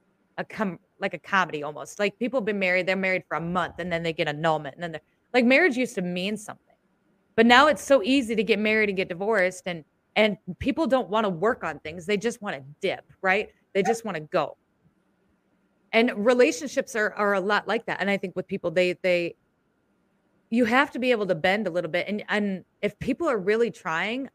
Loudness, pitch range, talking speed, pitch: -25 LUFS, 180-225 Hz, 230 wpm, 200 Hz